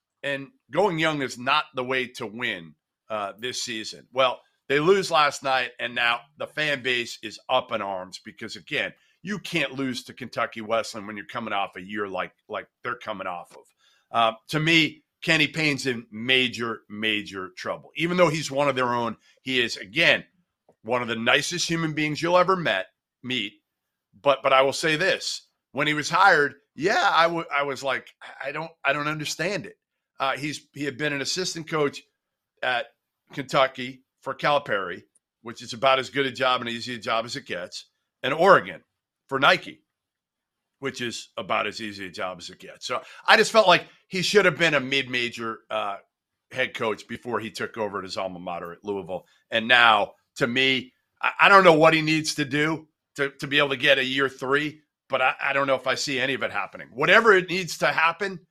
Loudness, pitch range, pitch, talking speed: -23 LUFS, 120-155 Hz, 135 Hz, 205 wpm